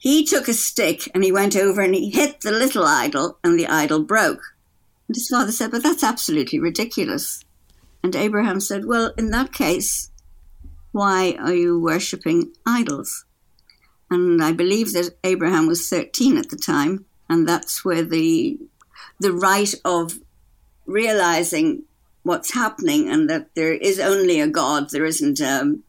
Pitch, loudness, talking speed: 210 Hz, -20 LUFS, 160 wpm